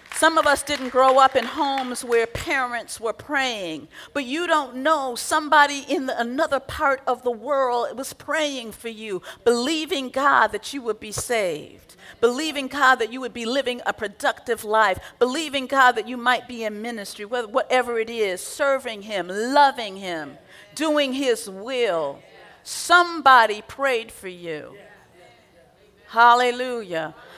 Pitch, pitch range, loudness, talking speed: 250 Hz, 225-280 Hz, -22 LUFS, 150 wpm